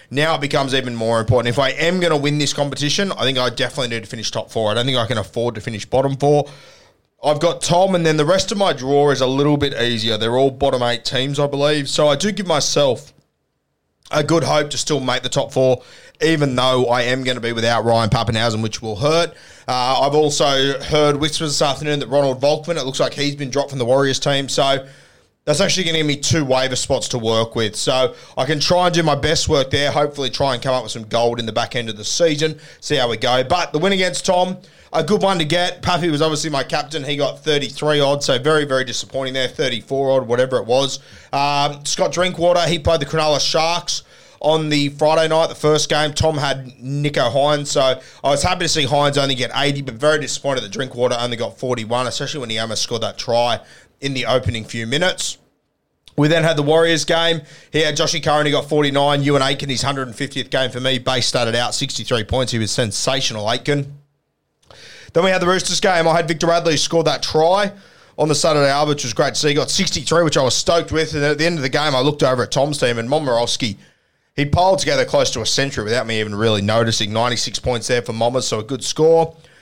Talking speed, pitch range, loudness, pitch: 240 wpm, 125-155 Hz, -18 LUFS, 140 Hz